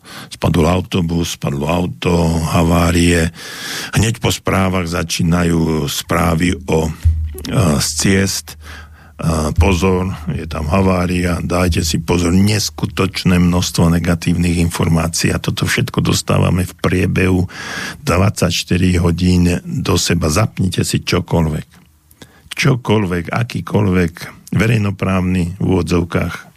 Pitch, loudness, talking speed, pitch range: 85 Hz, -16 LUFS, 100 wpm, 85-90 Hz